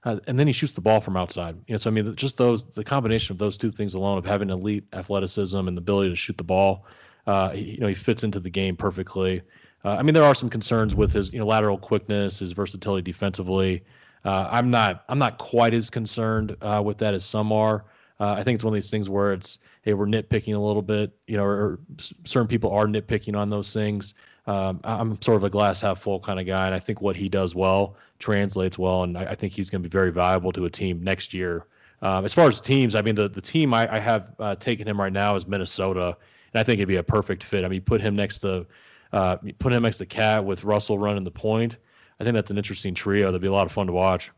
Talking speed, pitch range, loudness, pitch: 265 wpm, 95-110 Hz, -24 LUFS, 105 Hz